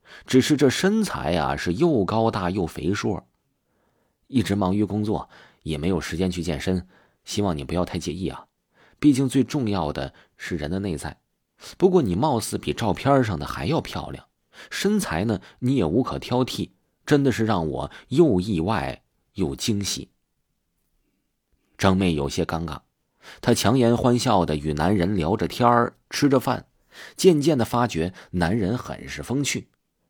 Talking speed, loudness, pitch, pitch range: 225 characters per minute, -23 LUFS, 100 Hz, 85-125 Hz